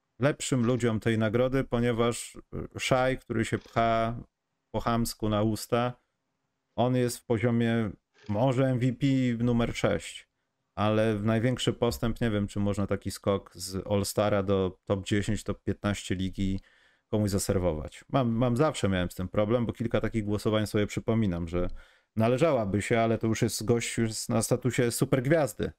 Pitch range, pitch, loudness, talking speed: 100-120 Hz, 115 Hz, -28 LUFS, 150 wpm